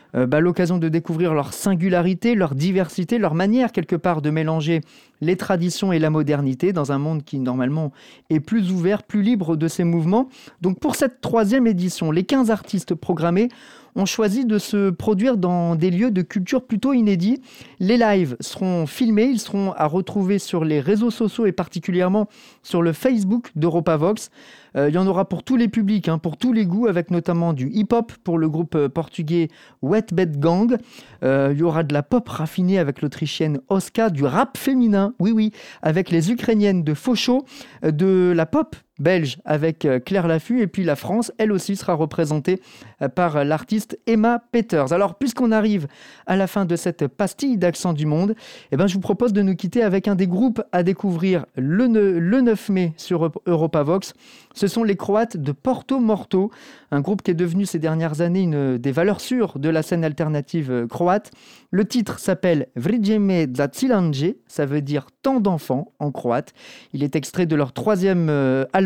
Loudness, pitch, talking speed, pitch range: -20 LUFS, 185 Hz, 185 wpm, 160-215 Hz